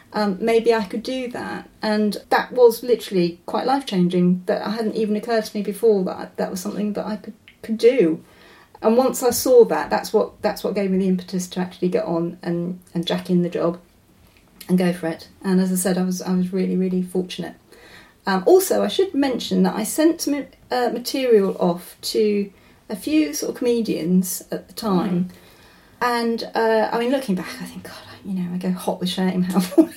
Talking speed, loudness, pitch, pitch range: 210 wpm, -21 LUFS, 205 Hz, 180-230 Hz